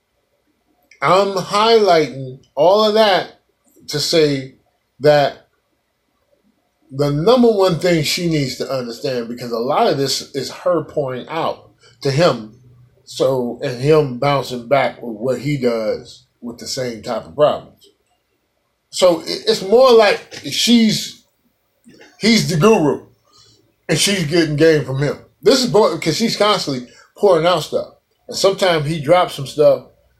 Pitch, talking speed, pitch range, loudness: 150 Hz, 140 wpm, 130-180 Hz, -16 LUFS